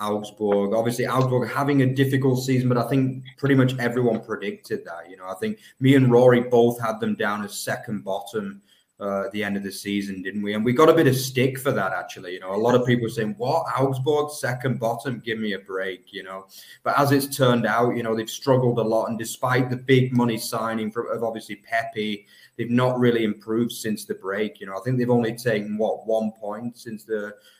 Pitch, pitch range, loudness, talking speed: 115 Hz, 105-130 Hz, -23 LUFS, 230 wpm